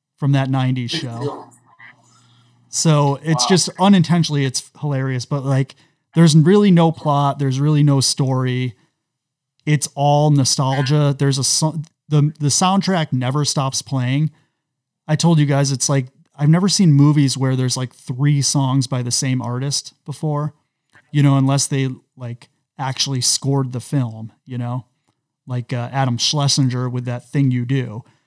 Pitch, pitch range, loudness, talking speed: 140 Hz, 130-150 Hz, -17 LUFS, 150 wpm